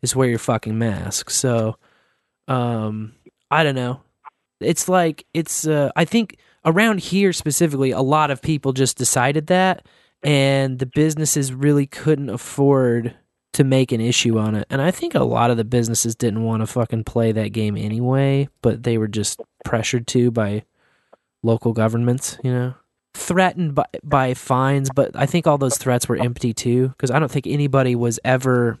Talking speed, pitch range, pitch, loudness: 175 wpm, 120-145 Hz, 130 Hz, -19 LUFS